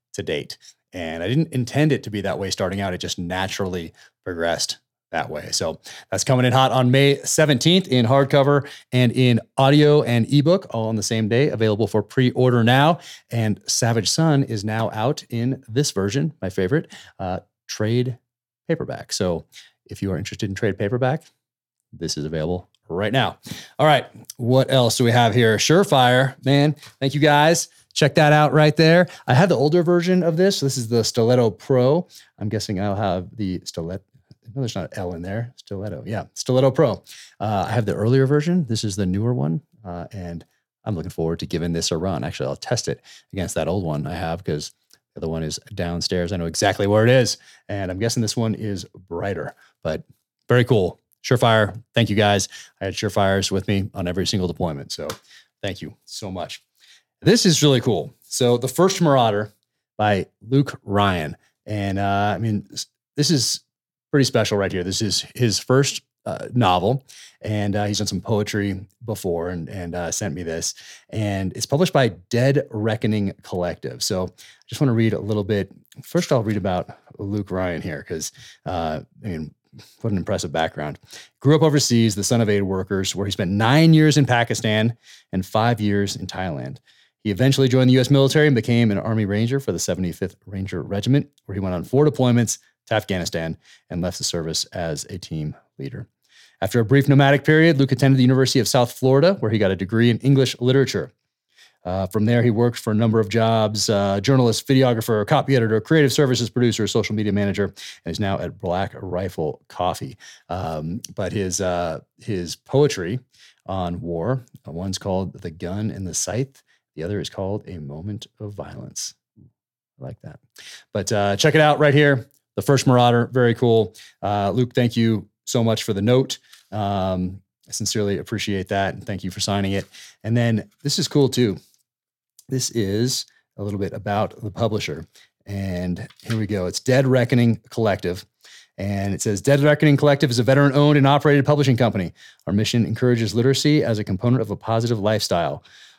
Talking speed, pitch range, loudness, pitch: 190 wpm, 100-130 Hz, -20 LUFS, 110 Hz